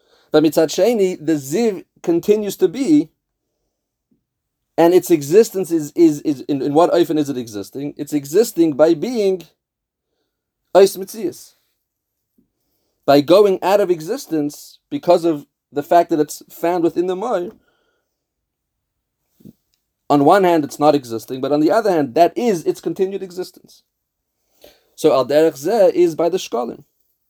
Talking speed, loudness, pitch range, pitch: 140 wpm, -17 LUFS, 150-200 Hz, 170 Hz